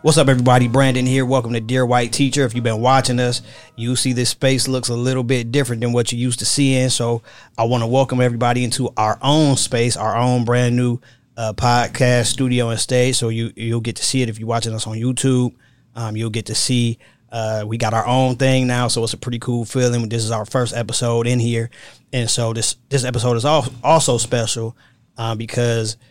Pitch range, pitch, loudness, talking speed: 115-130 Hz, 120 Hz, -18 LUFS, 225 wpm